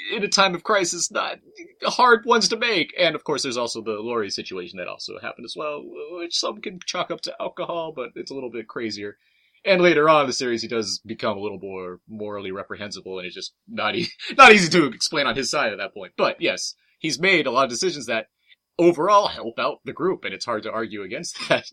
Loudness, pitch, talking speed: -21 LUFS, 165 Hz, 240 wpm